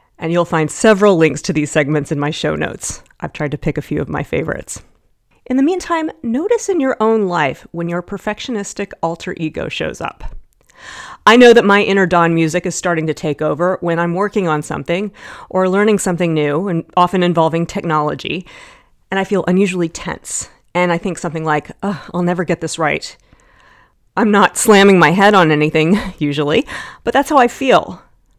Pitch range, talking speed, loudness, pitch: 160-210 Hz, 190 wpm, -15 LUFS, 180 Hz